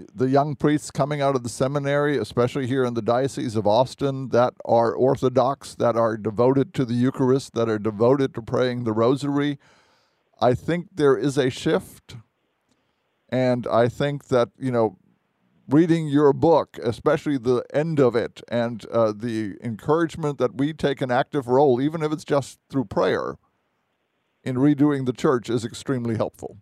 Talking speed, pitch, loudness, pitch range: 165 wpm, 130 Hz, -22 LUFS, 120-145 Hz